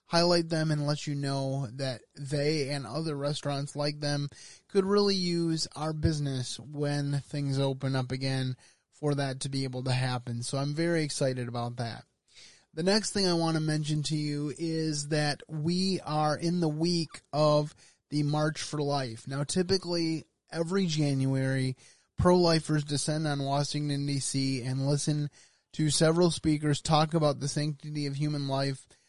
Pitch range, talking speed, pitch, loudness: 135-160 Hz, 165 wpm, 145 Hz, -30 LUFS